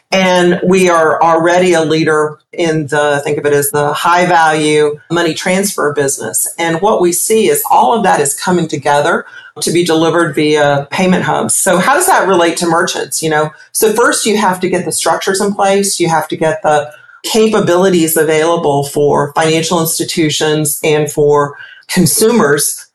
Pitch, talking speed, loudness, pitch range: 165 Hz, 175 wpm, -11 LUFS, 150-185 Hz